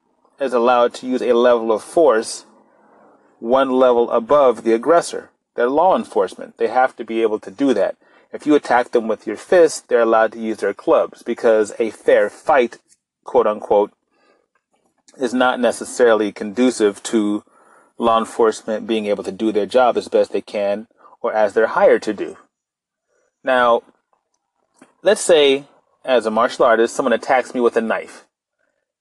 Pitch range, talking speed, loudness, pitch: 110-130 Hz, 165 wpm, -17 LUFS, 120 Hz